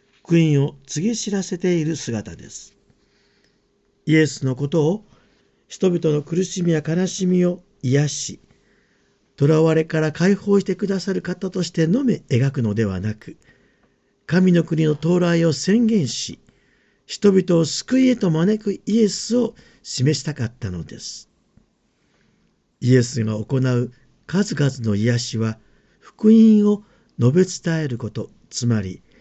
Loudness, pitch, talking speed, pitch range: -20 LUFS, 160 Hz, 240 characters per minute, 130-190 Hz